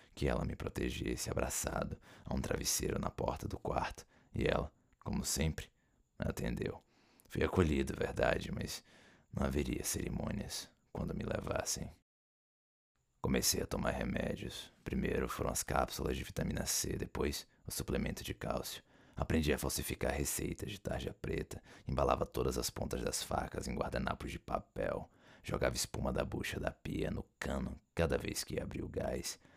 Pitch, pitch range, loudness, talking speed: 75 Hz, 70-80 Hz, -38 LUFS, 150 wpm